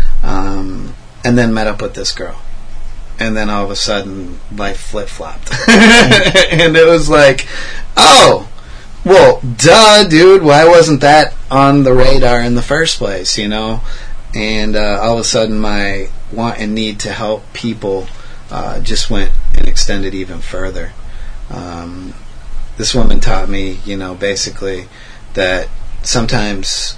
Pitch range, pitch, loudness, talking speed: 95-125 Hz, 110 Hz, -10 LUFS, 150 wpm